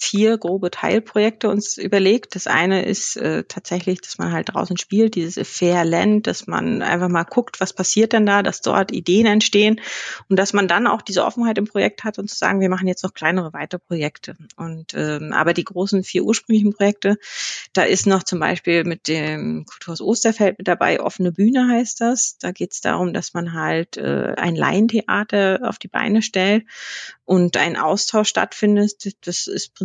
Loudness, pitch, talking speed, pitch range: -19 LUFS, 195 Hz, 185 wpm, 180-215 Hz